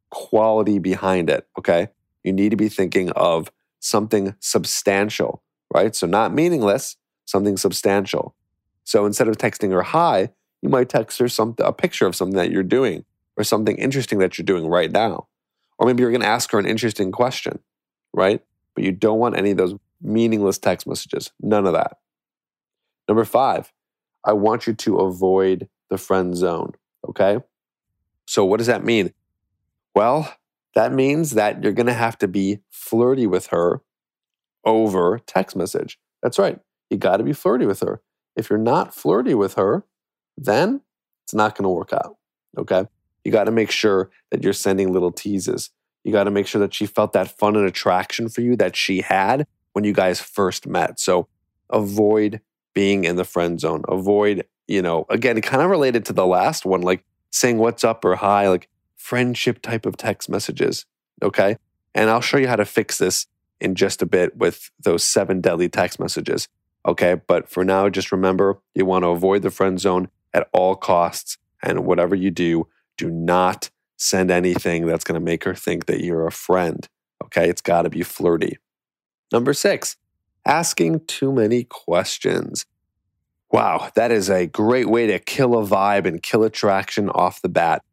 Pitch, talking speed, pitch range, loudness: 100 Hz, 180 wpm, 90-110 Hz, -20 LUFS